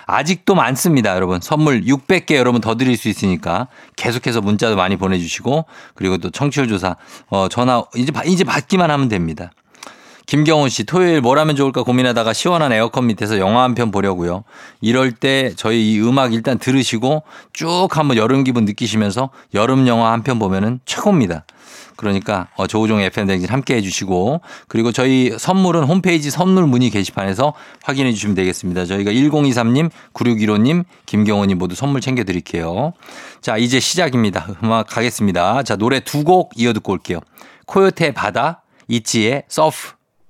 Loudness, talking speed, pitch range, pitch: -16 LUFS, 360 characters per minute, 105-140 Hz, 120 Hz